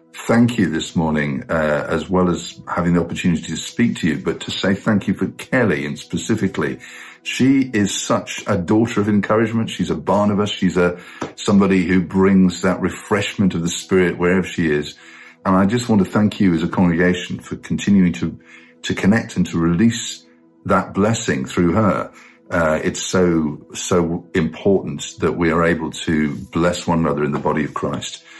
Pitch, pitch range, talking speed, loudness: 90 Hz, 85-100 Hz, 185 wpm, -18 LUFS